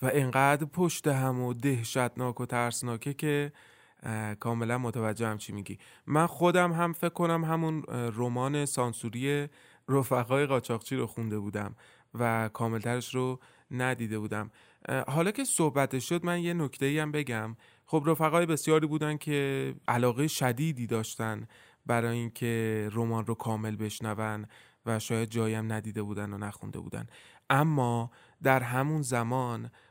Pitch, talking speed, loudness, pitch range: 125 Hz, 135 wpm, -30 LUFS, 115-145 Hz